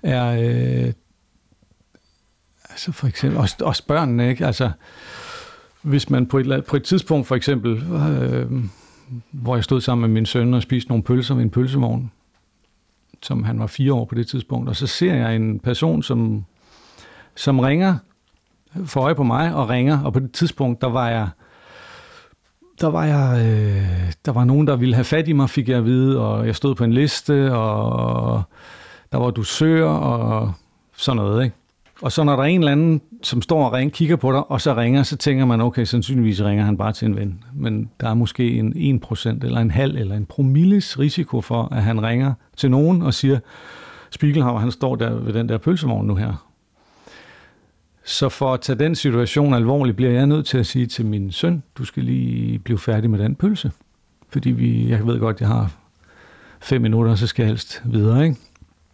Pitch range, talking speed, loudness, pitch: 110-140 Hz, 200 wpm, -19 LUFS, 125 Hz